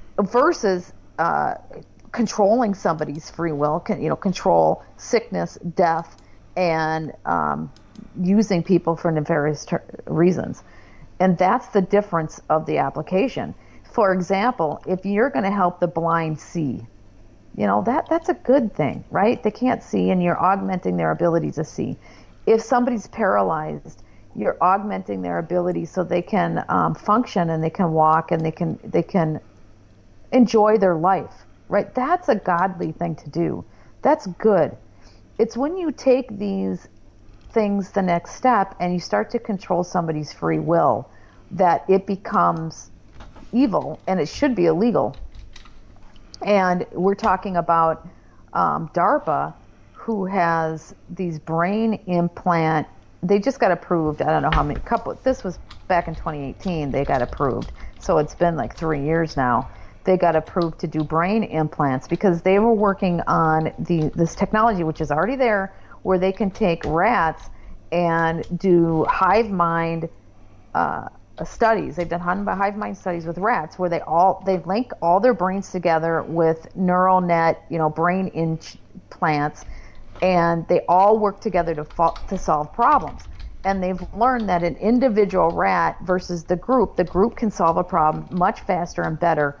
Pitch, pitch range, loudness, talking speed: 175 Hz, 160-200 Hz, -21 LUFS, 155 wpm